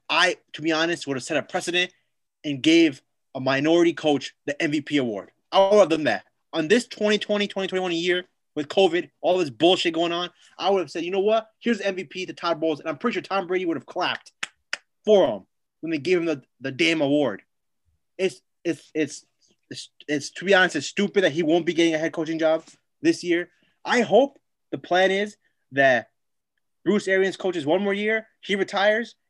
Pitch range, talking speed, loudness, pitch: 160-195 Hz, 210 wpm, -23 LUFS, 175 Hz